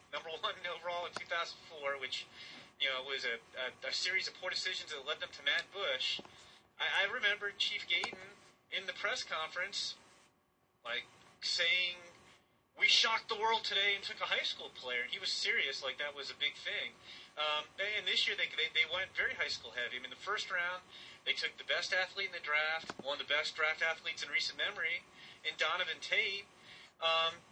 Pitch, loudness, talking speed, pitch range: 175 Hz, -35 LUFS, 200 wpm, 155-205 Hz